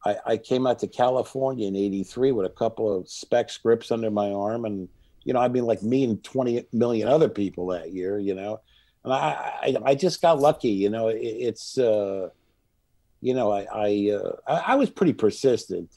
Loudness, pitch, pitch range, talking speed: -24 LUFS, 110 Hz, 100-125 Hz, 205 wpm